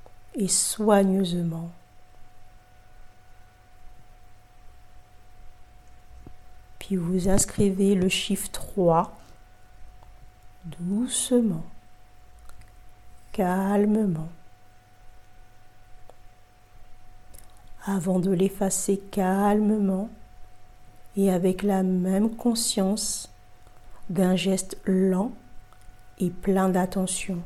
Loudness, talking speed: -25 LUFS, 55 wpm